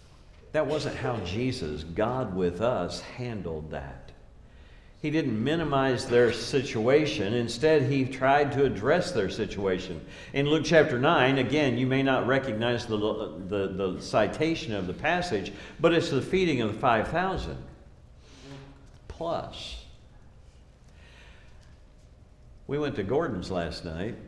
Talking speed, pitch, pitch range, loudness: 130 wpm, 120 Hz, 90-140 Hz, -27 LUFS